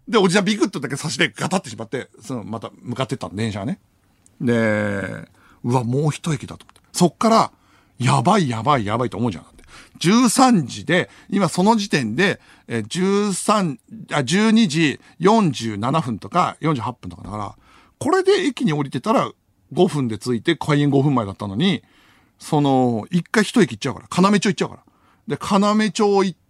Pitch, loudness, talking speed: 145 Hz, -20 LUFS, 320 characters per minute